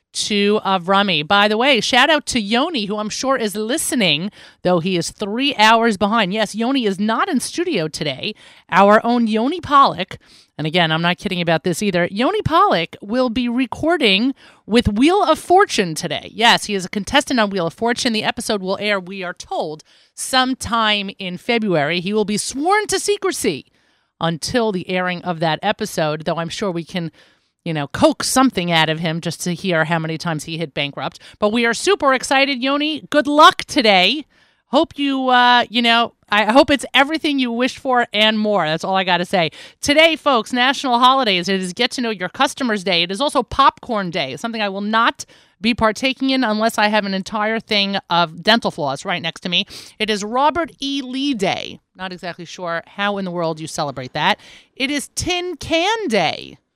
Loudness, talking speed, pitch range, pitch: -17 LUFS, 200 wpm, 180-260 Hz, 215 Hz